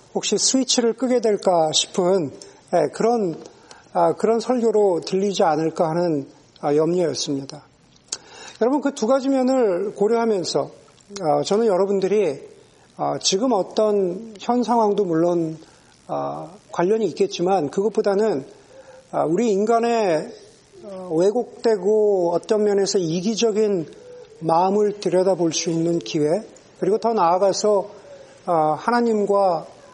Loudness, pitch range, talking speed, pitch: -20 LUFS, 175-225 Hz, 235 characters per minute, 200 Hz